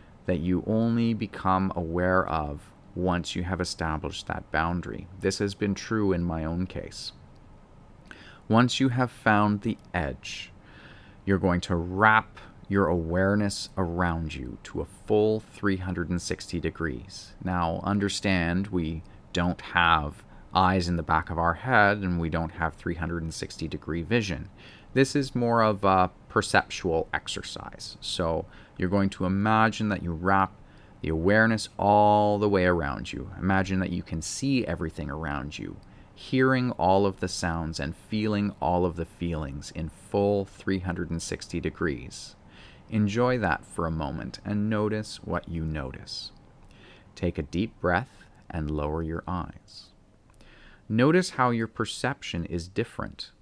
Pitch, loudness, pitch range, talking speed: 95 Hz, -27 LUFS, 85-105 Hz, 145 wpm